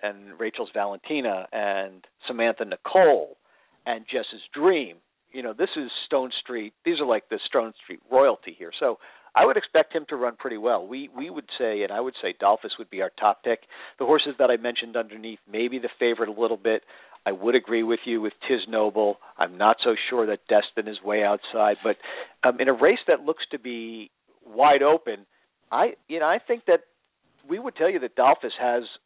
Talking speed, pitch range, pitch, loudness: 205 wpm, 105-155 Hz, 115 Hz, -24 LUFS